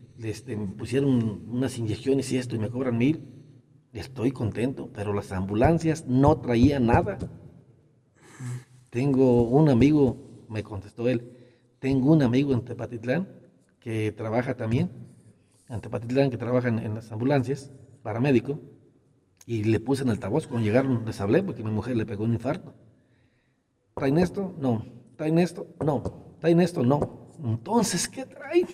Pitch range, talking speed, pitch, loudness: 115-140 Hz, 150 wpm, 125 Hz, -26 LUFS